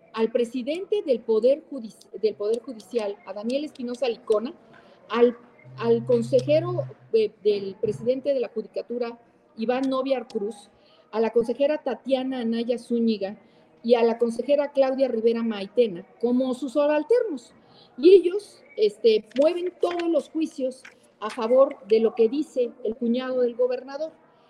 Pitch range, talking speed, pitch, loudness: 225-280 Hz, 140 wpm, 245 Hz, -24 LUFS